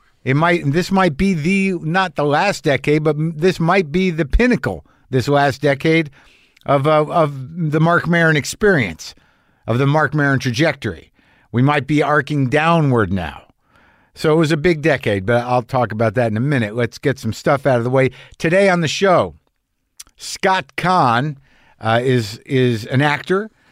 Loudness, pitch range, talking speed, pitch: -17 LUFS, 125-170 Hz, 175 wpm, 145 Hz